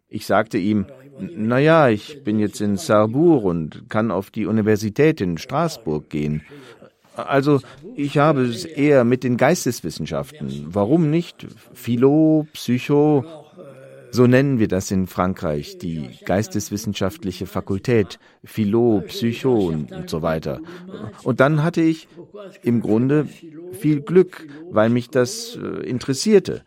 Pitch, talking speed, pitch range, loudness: 125 Hz, 125 wpm, 105-150 Hz, -20 LUFS